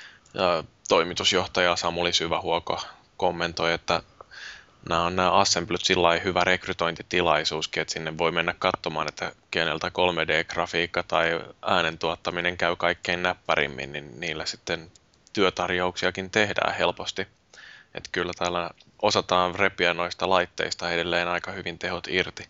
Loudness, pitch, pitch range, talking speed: -25 LUFS, 90 Hz, 85-90 Hz, 120 wpm